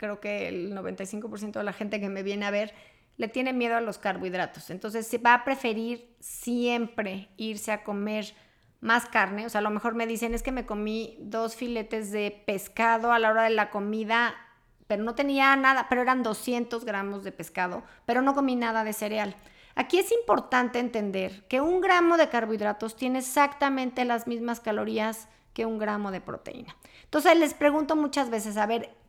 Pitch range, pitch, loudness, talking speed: 210-245 Hz, 225 Hz, -27 LUFS, 190 wpm